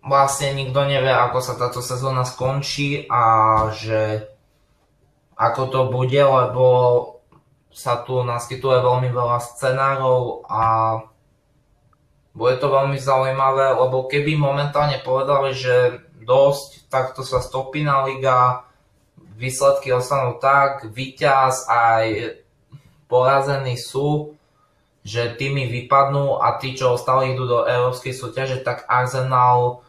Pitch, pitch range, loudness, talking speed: 130 Hz, 125-140 Hz, -19 LUFS, 110 wpm